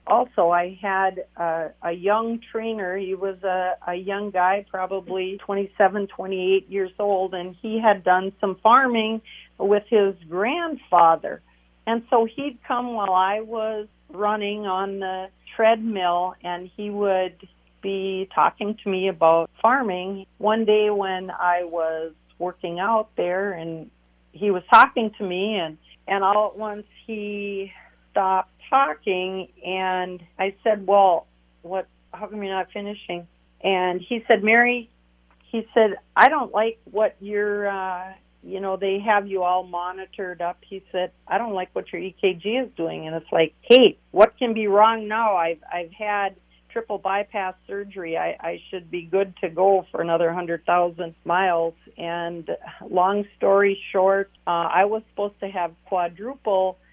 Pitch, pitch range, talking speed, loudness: 195 Hz, 180-210 Hz, 155 wpm, -22 LUFS